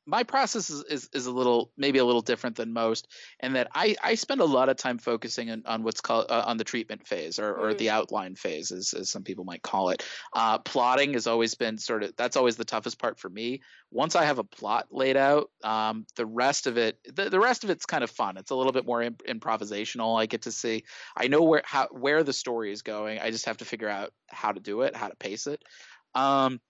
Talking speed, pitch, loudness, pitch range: 255 wpm, 120 Hz, -28 LUFS, 110-135 Hz